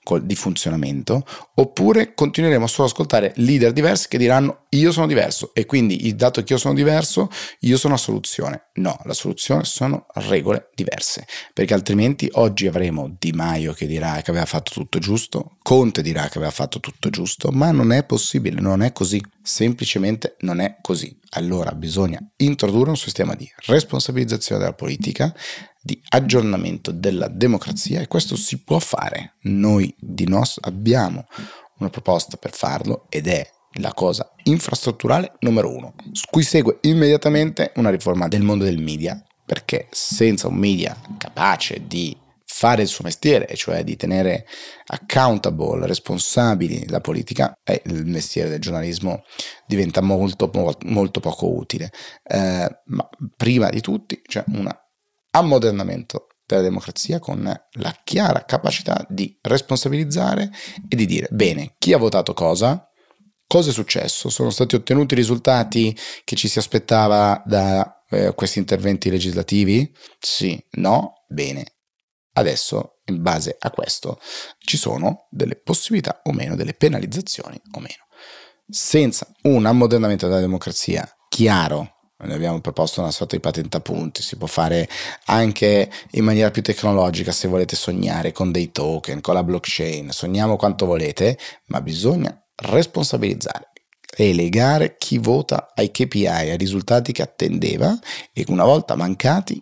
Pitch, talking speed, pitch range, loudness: 110 Hz, 145 wpm, 90-135 Hz, -20 LUFS